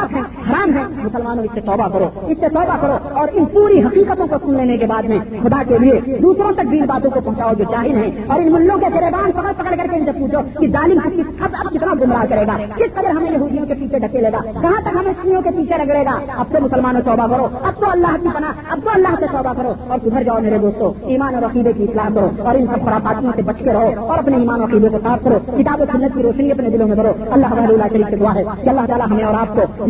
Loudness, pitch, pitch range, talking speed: -15 LUFS, 260 Hz, 225-320 Hz, 240 wpm